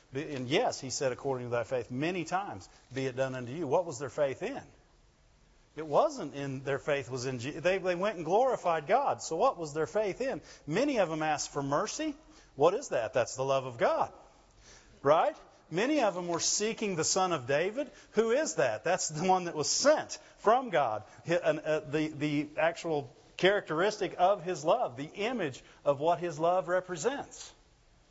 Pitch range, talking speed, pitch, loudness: 140-190 Hz, 190 wpm, 160 Hz, -31 LUFS